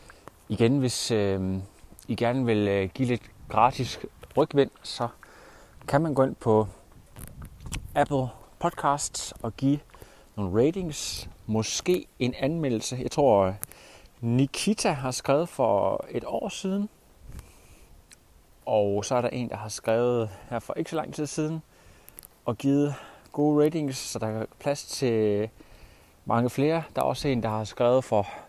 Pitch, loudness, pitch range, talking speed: 125 Hz, -27 LUFS, 110-140 Hz, 145 wpm